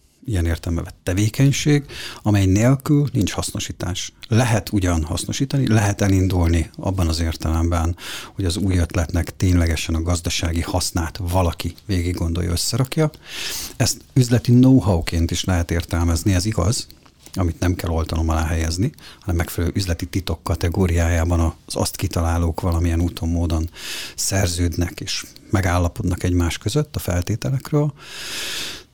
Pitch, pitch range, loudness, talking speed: 90 Hz, 85-105 Hz, -21 LUFS, 125 wpm